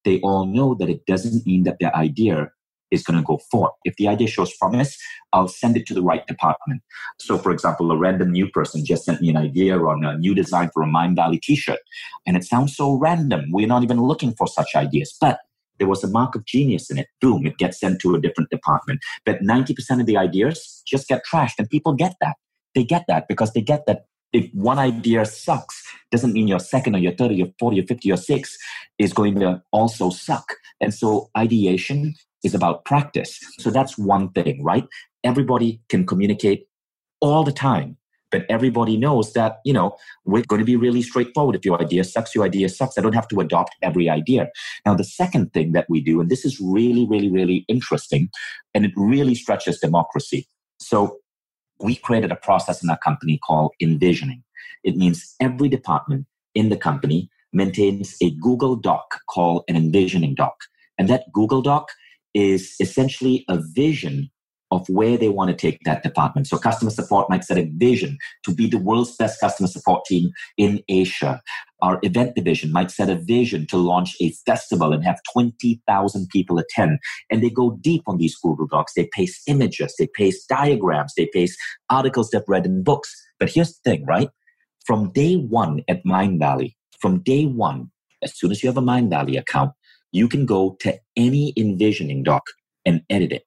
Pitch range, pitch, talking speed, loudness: 90-130 Hz, 110 Hz, 200 wpm, -20 LUFS